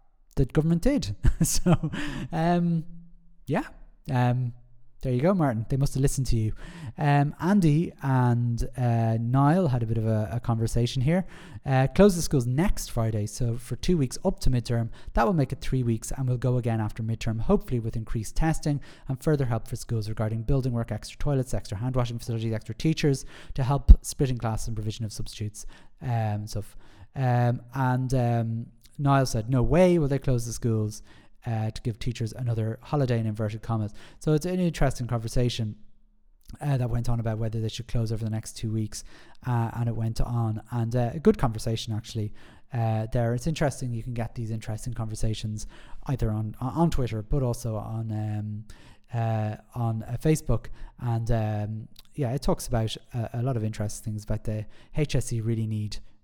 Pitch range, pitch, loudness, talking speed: 110-140 Hz, 120 Hz, -27 LUFS, 190 wpm